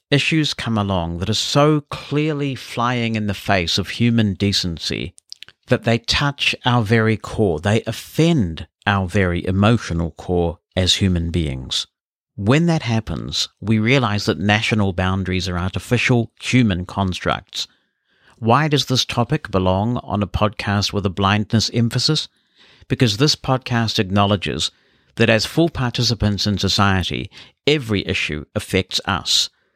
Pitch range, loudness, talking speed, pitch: 95-120 Hz, -19 LUFS, 135 wpm, 105 Hz